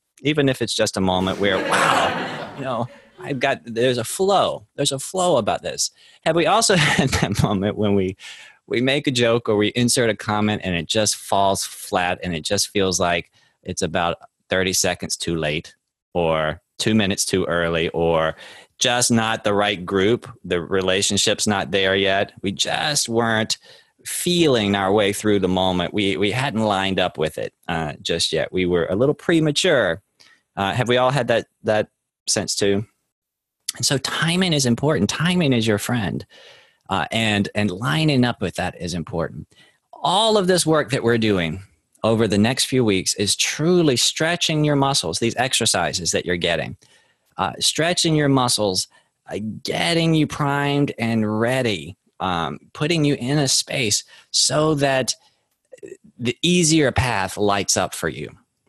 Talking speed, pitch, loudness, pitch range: 170 wpm, 110 Hz, -20 LUFS, 95-140 Hz